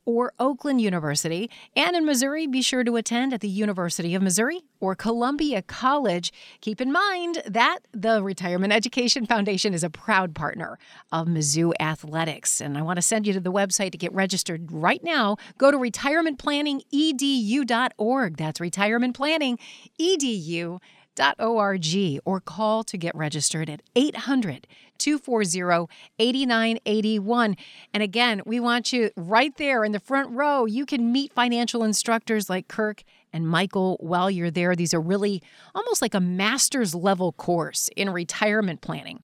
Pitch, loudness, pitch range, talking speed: 215 Hz, -24 LUFS, 180-250 Hz, 145 wpm